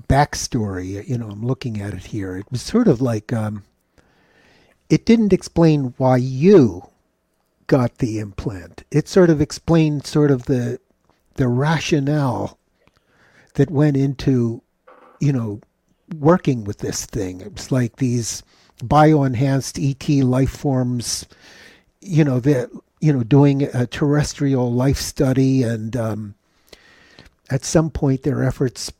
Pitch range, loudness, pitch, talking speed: 115-150 Hz, -19 LUFS, 130 Hz, 135 wpm